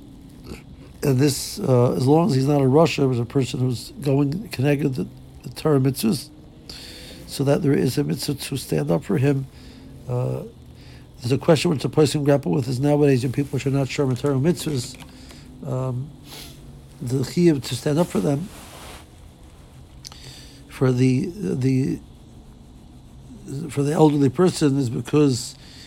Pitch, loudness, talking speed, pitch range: 140 Hz, -21 LUFS, 155 wpm, 130-145 Hz